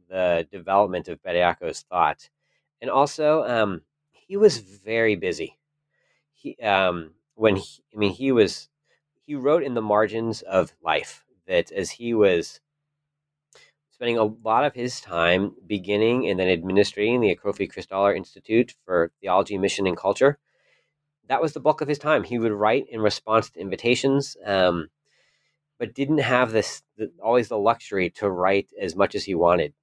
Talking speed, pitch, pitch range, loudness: 160 wpm, 110 Hz, 100-145 Hz, -23 LUFS